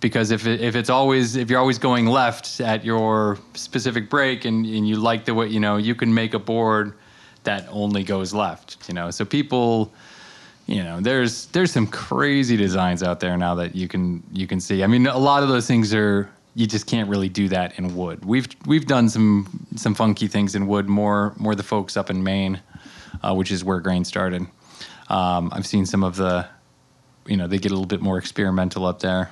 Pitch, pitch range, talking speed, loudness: 105 Hz, 95-115 Hz, 220 wpm, -21 LUFS